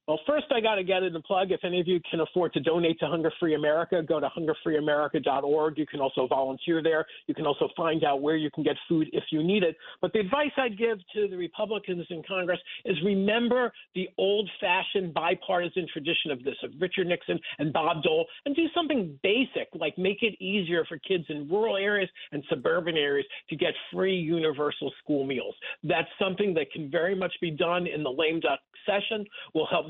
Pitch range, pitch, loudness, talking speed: 160-200 Hz, 175 Hz, -28 LUFS, 210 wpm